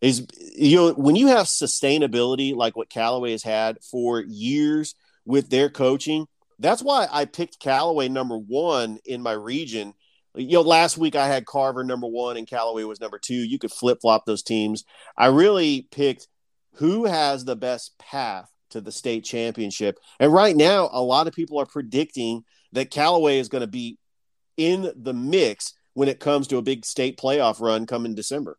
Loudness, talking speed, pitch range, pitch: -22 LUFS, 185 wpm, 115-160 Hz, 135 Hz